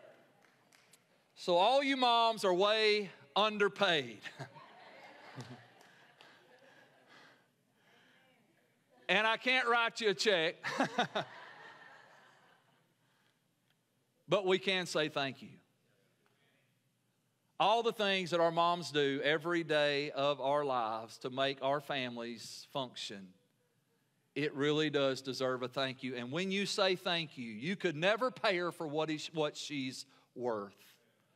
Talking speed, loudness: 115 wpm, -33 LUFS